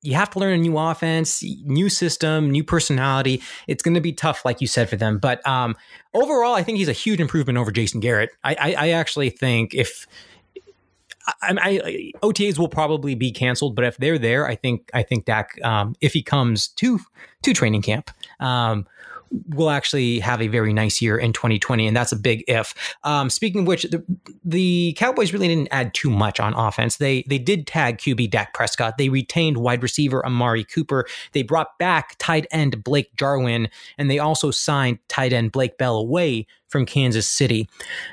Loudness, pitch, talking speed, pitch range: -21 LUFS, 135 Hz, 195 wpm, 120-160 Hz